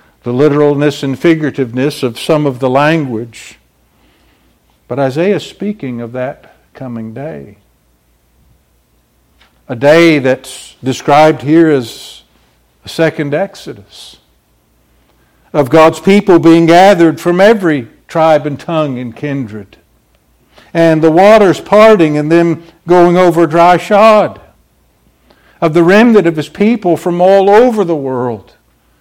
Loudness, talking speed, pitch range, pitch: -9 LUFS, 120 wpm, 110-170 Hz, 145 Hz